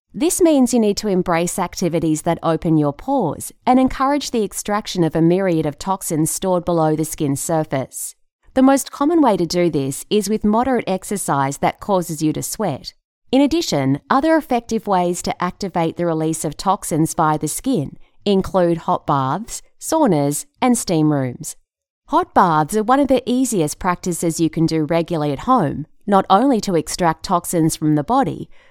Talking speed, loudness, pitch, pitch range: 175 wpm, -18 LUFS, 180 Hz, 160-235 Hz